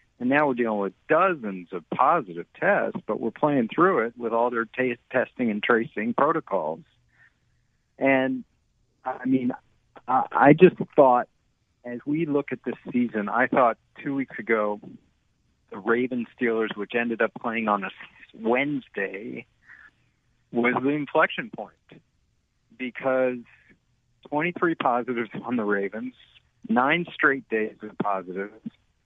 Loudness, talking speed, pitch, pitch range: -24 LUFS, 130 wpm, 120 Hz, 110-135 Hz